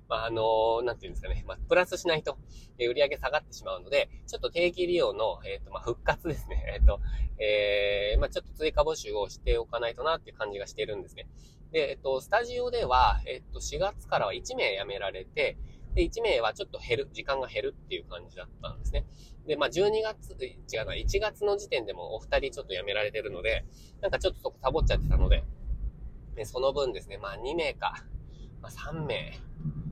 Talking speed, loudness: 415 characters per minute, -30 LUFS